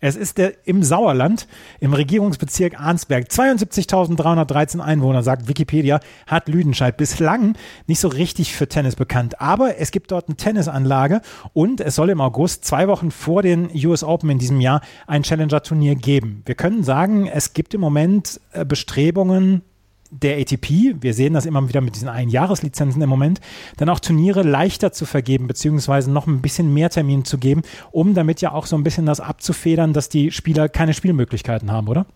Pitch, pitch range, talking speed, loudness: 155 Hz, 140-175 Hz, 175 wpm, -18 LUFS